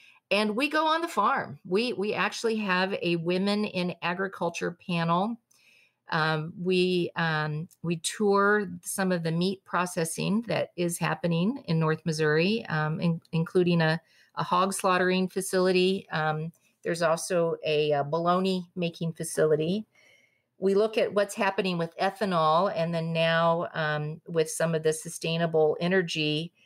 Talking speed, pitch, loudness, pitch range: 145 wpm, 175 Hz, -27 LUFS, 165-190 Hz